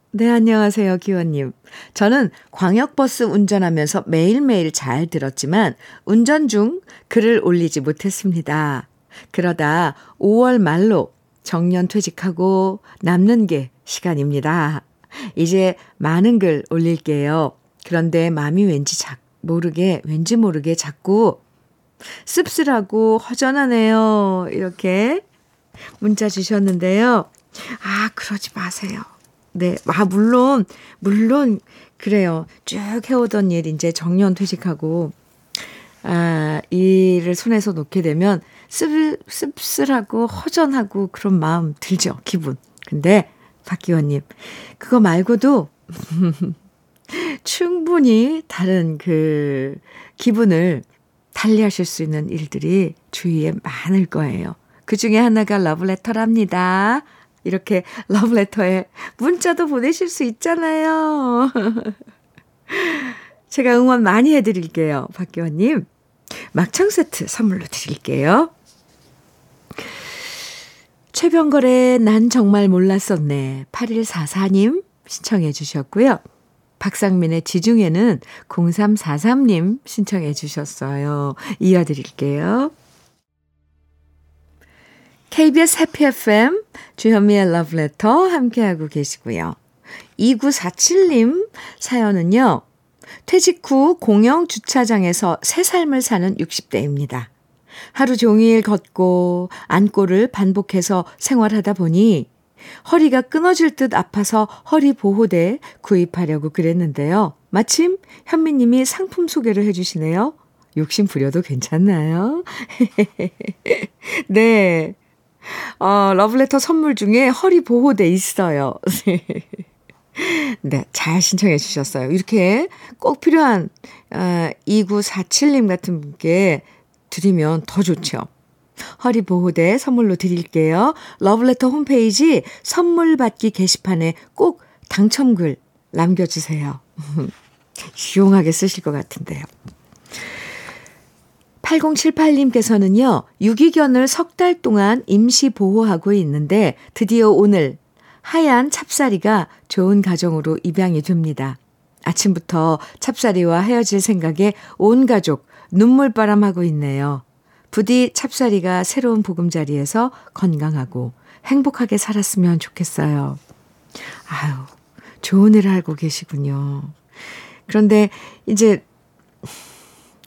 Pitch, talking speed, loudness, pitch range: 200 Hz, 220 characters per minute, -17 LUFS, 170-235 Hz